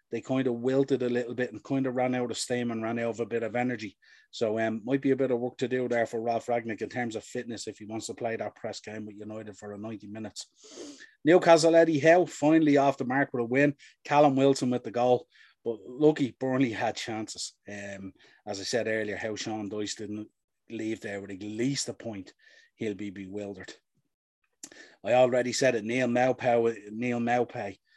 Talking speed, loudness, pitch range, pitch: 215 wpm, -28 LUFS, 110-130 Hz, 120 Hz